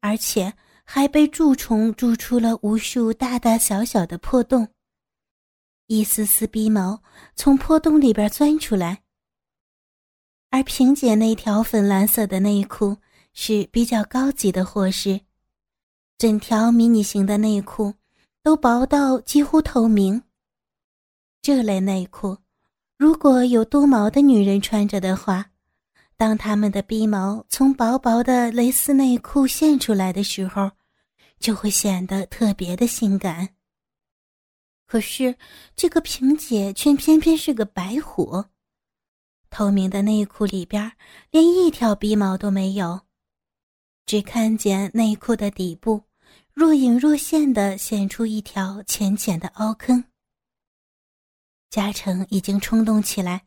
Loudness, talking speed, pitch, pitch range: -20 LUFS, 190 characters per minute, 220 Hz, 200-250 Hz